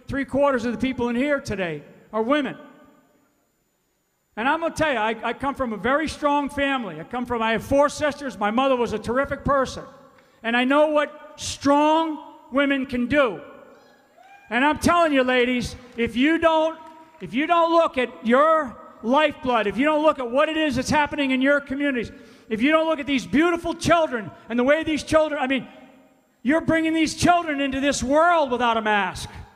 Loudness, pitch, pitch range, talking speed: -22 LUFS, 280 Hz, 245-305 Hz, 200 wpm